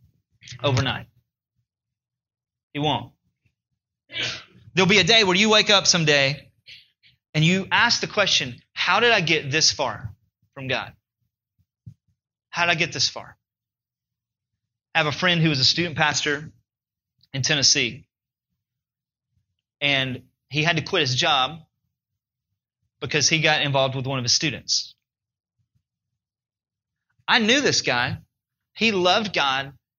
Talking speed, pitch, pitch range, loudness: 130 wpm, 130 Hz, 120-155 Hz, -20 LUFS